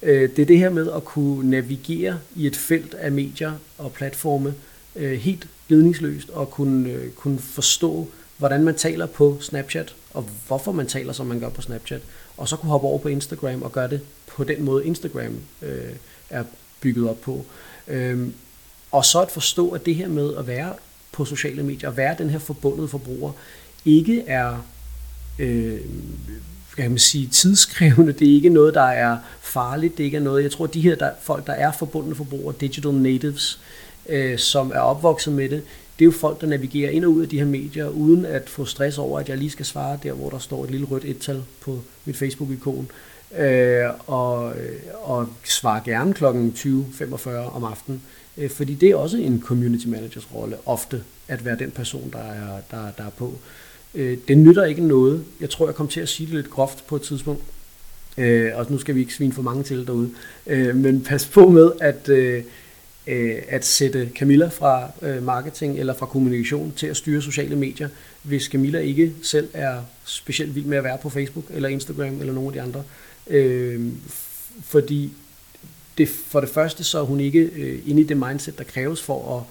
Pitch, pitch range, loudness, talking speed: 140 Hz, 130-150 Hz, -20 LUFS, 190 wpm